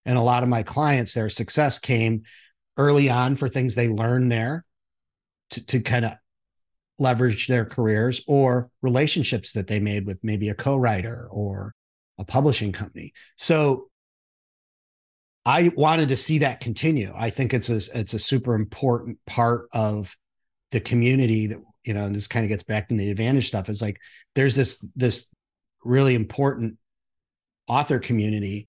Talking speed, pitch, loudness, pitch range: 160 wpm, 120 Hz, -23 LUFS, 105-130 Hz